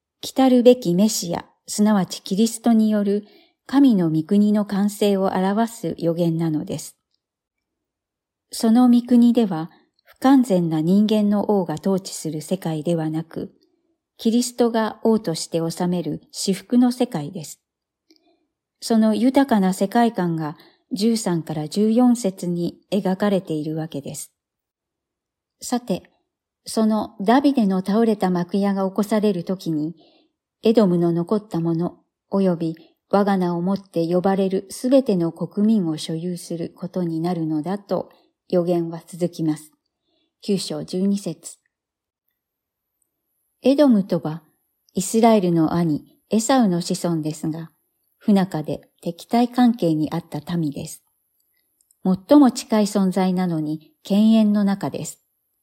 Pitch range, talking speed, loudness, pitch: 170-230 Hz, 240 characters per minute, -20 LUFS, 195 Hz